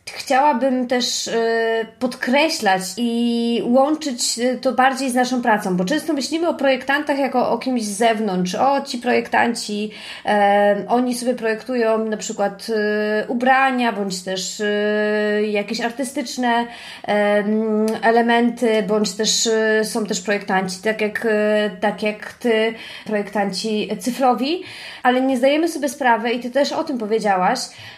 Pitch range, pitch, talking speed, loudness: 210-255 Hz, 230 Hz, 120 wpm, -19 LUFS